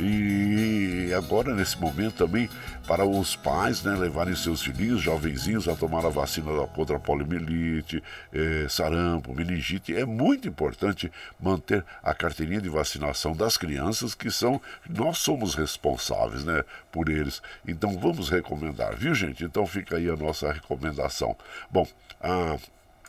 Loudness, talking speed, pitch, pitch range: -27 LUFS, 140 wpm, 85 Hz, 80-100 Hz